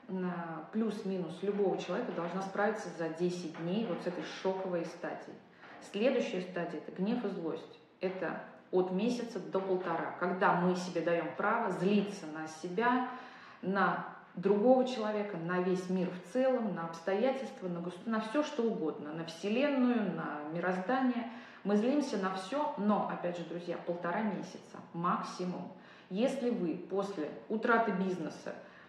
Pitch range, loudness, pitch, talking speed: 175-220 Hz, -34 LUFS, 190 Hz, 140 wpm